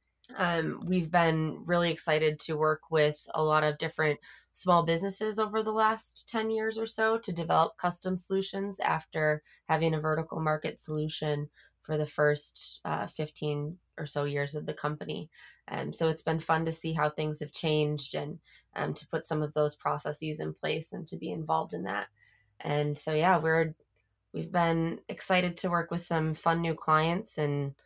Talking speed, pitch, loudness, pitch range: 185 wpm, 160 Hz, -30 LUFS, 150-175 Hz